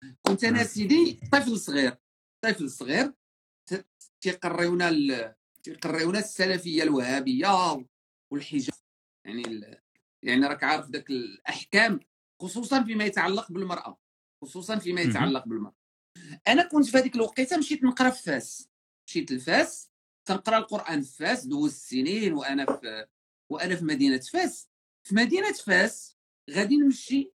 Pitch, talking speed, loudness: 190 Hz, 120 wpm, -26 LUFS